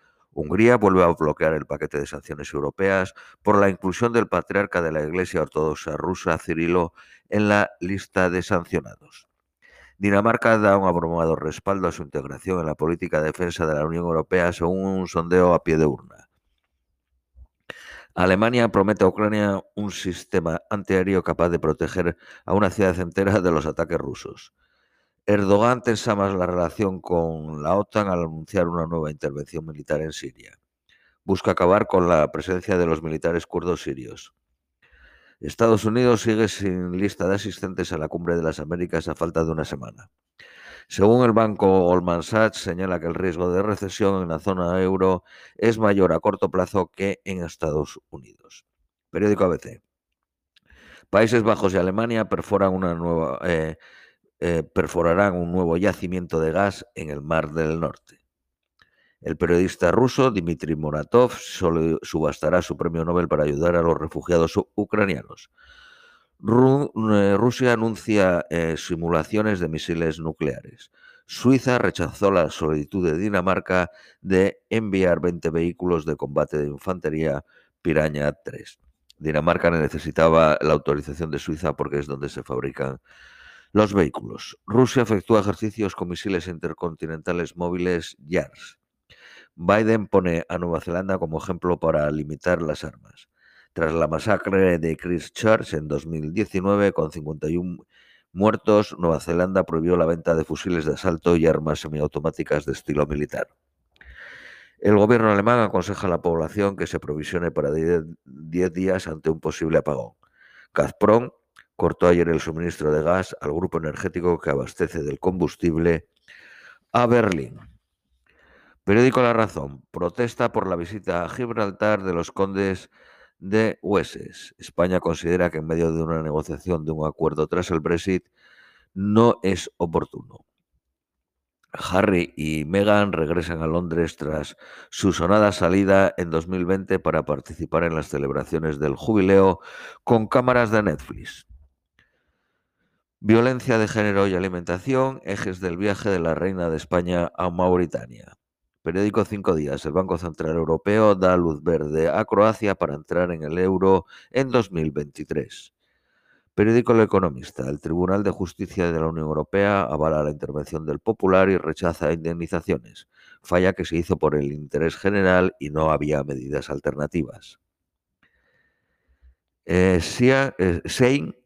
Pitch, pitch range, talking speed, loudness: 90 Hz, 80-100 Hz, 140 wpm, -22 LUFS